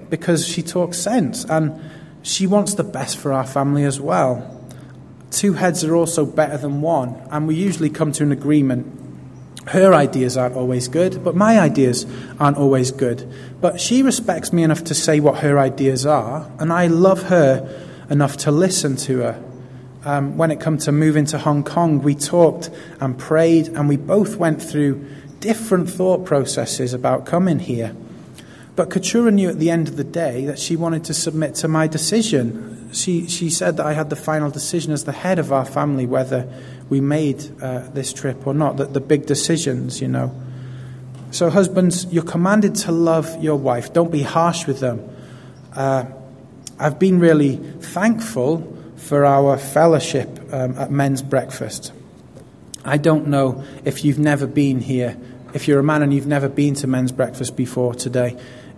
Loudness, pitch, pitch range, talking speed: -18 LUFS, 145 Hz, 130-165 Hz, 180 wpm